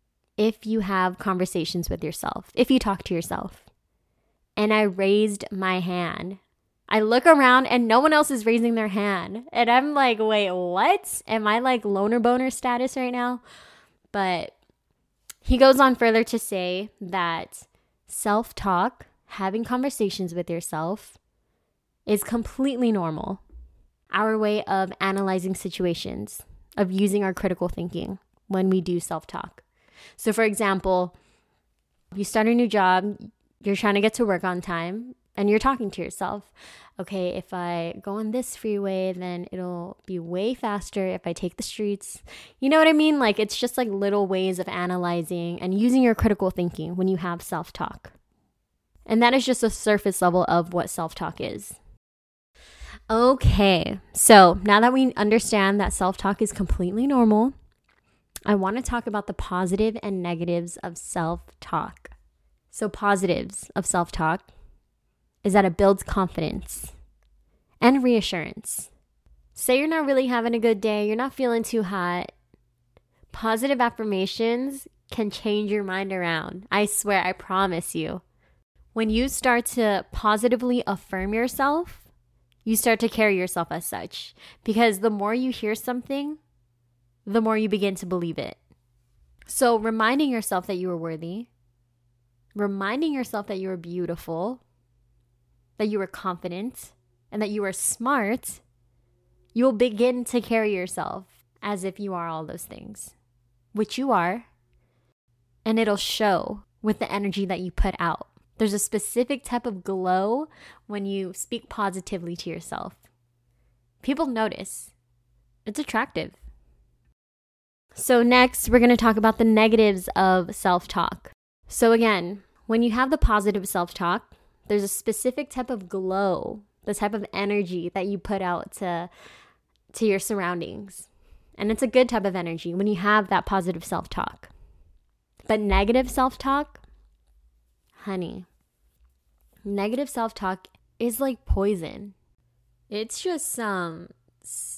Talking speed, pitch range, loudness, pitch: 150 wpm, 175-225 Hz, -24 LUFS, 200 Hz